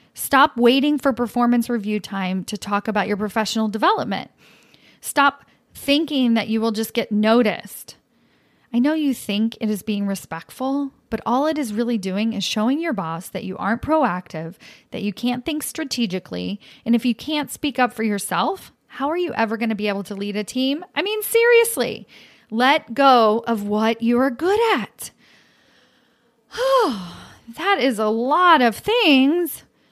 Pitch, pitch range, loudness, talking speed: 235 Hz, 210-285 Hz, -20 LUFS, 170 wpm